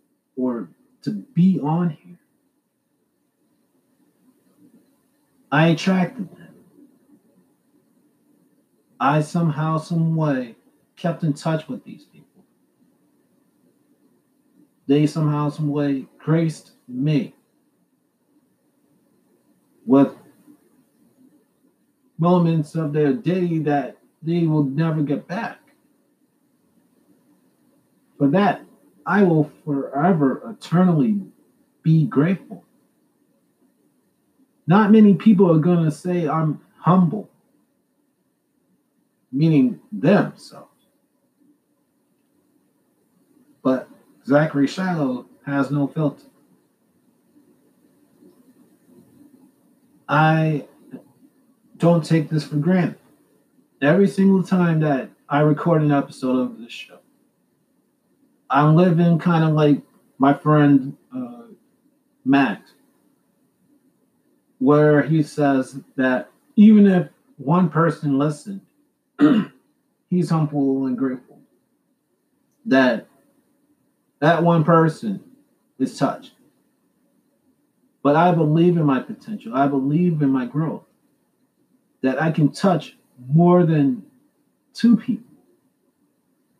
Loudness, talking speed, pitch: -19 LUFS, 85 wpm, 175 Hz